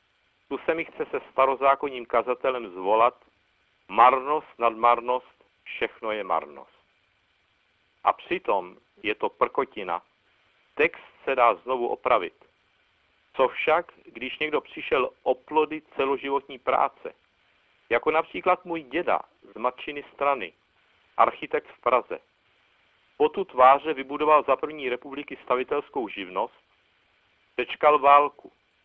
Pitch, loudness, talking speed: 150 Hz, -25 LUFS, 110 wpm